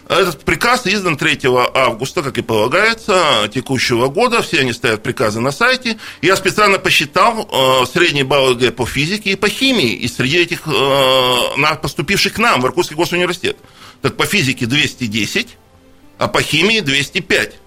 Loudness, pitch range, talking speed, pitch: -14 LUFS, 130-190 Hz, 145 wpm, 155 Hz